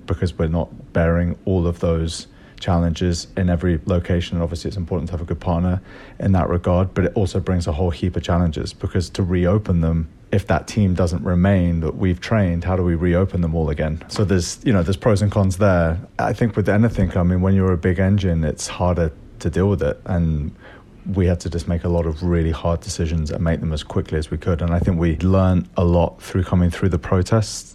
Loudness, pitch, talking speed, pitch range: -20 LUFS, 90 Hz, 235 wpm, 85-95 Hz